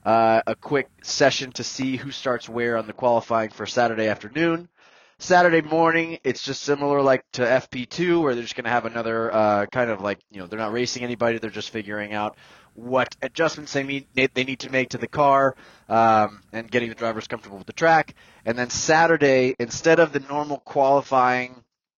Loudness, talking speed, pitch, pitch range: -22 LUFS, 195 wpm, 125 Hz, 115-140 Hz